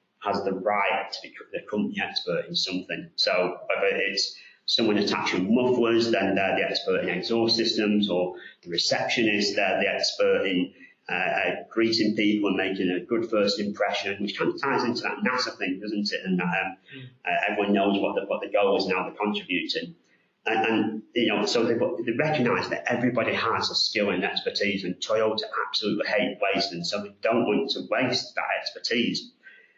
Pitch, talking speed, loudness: 105 Hz, 185 wpm, -25 LUFS